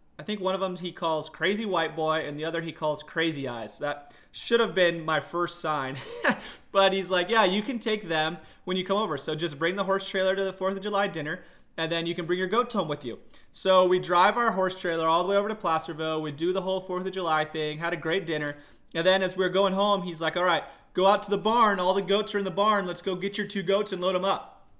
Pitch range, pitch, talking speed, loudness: 160-195 Hz, 180 Hz, 280 wpm, -27 LUFS